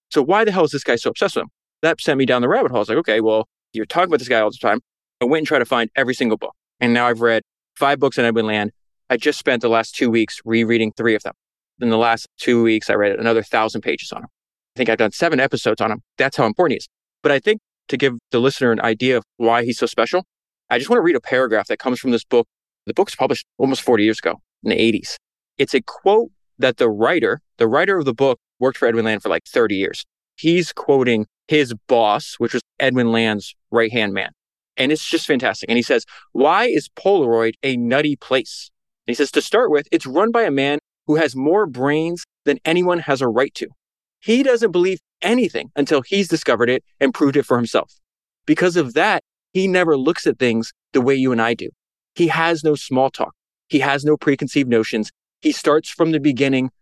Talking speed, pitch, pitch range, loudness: 240 wpm, 130 Hz, 115-155 Hz, -18 LUFS